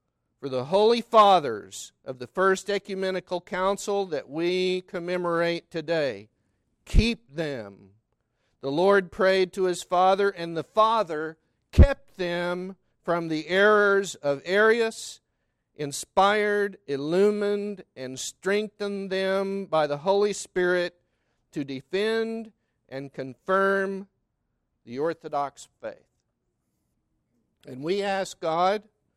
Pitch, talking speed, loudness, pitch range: 185 Hz, 105 wpm, -25 LUFS, 155-200 Hz